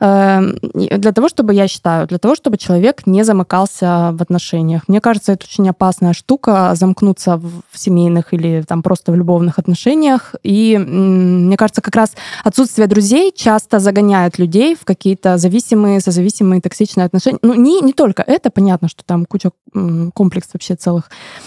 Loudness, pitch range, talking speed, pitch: -13 LUFS, 180-220 Hz, 155 wpm, 195 Hz